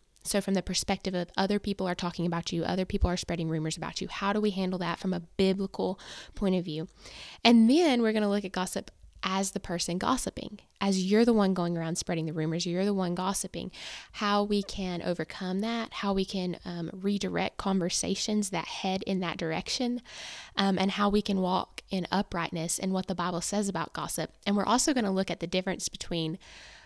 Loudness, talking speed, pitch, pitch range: -30 LUFS, 210 wpm, 190 Hz, 175-205 Hz